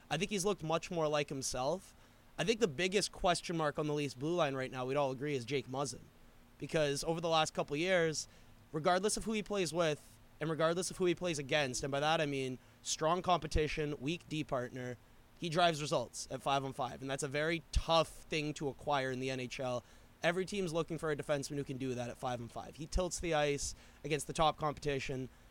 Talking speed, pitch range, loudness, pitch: 225 wpm, 130-165 Hz, -36 LUFS, 150 Hz